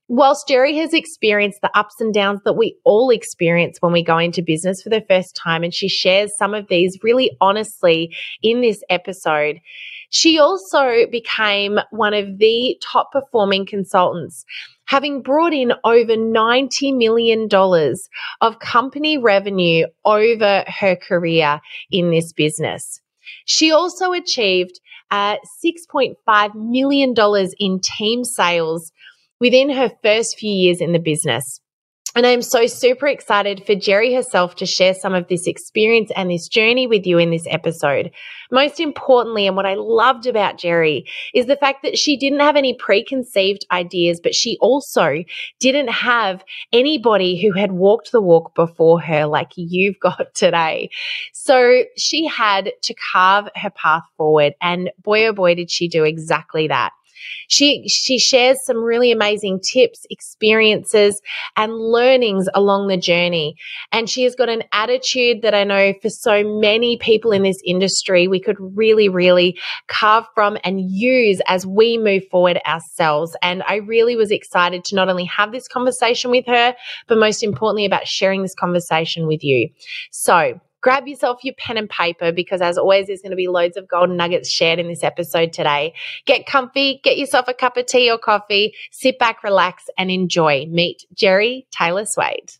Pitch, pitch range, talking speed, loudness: 210 Hz, 180-245 Hz, 165 wpm, -16 LUFS